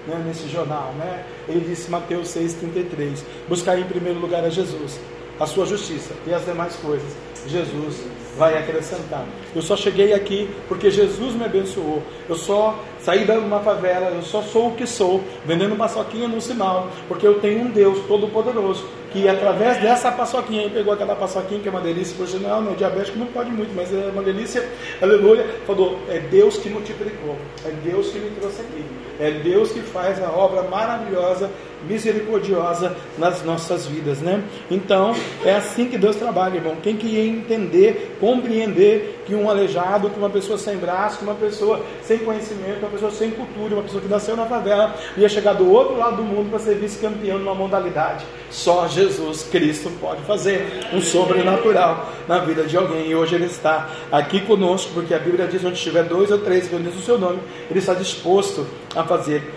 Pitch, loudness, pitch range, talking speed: 195 Hz, -20 LUFS, 175-215 Hz, 185 wpm